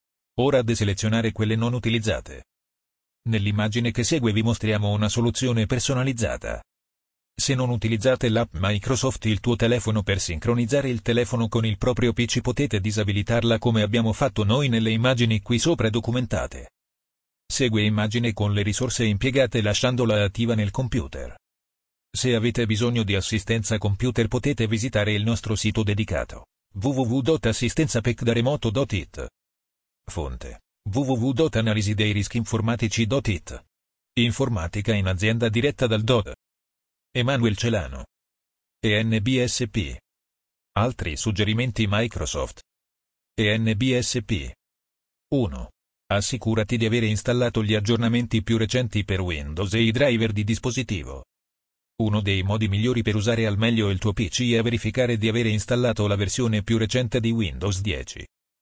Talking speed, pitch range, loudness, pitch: 120 wpm, 100-120 Hz, -23 LUFS, 110 Hz